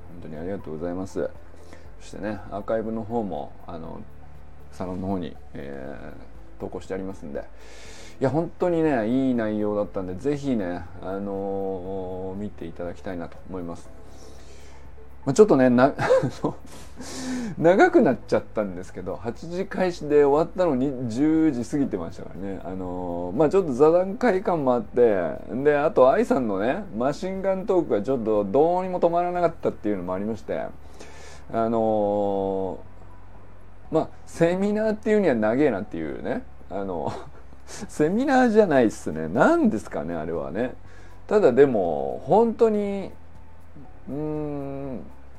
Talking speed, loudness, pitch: 305 characters per minute, -24 LUFS, 105 Hz